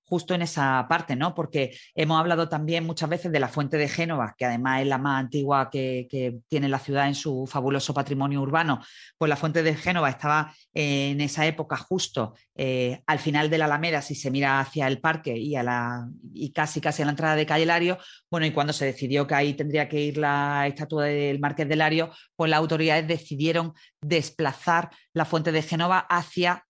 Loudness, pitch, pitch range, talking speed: -25 LUFS, 150 Hz, 140-160 Hz, 205 wpm